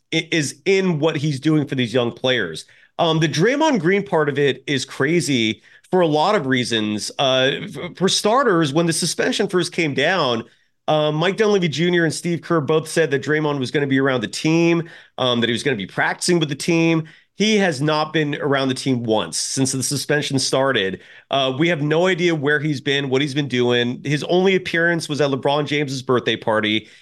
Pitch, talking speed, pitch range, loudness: 150 Hz, 210 wpm, 135-170 Hz, -19 LUFS